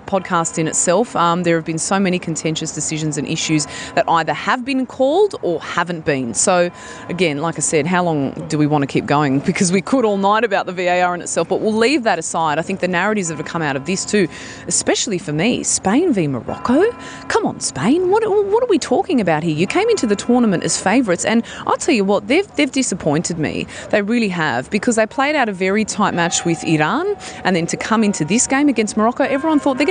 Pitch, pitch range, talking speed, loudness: 190 Hz, 165-245 Hz, 235 wpm, -17 LUFS